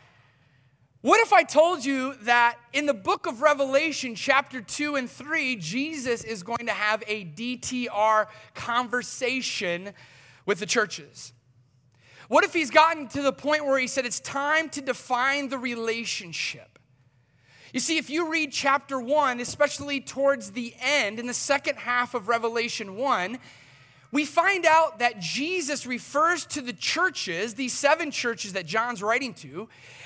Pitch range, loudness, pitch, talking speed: 210-285 Hz, -25 LUFS, 250 Hz, 150 wpm